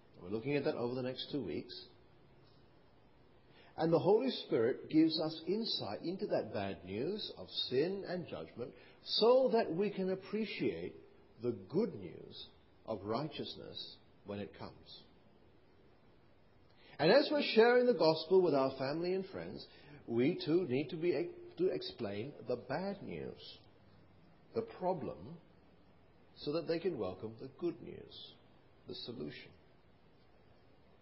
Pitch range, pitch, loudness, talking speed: 145-225 Hz, 180 Hz, -36 LUFS, 135 wpm